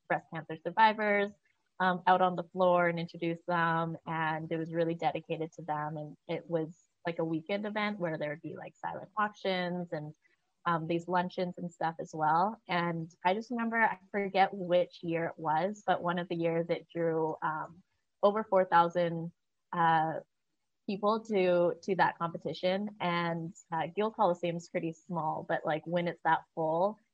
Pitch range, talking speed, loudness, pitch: 165-185 Hz, 175 wpm, -32 LUFS, 175 Hz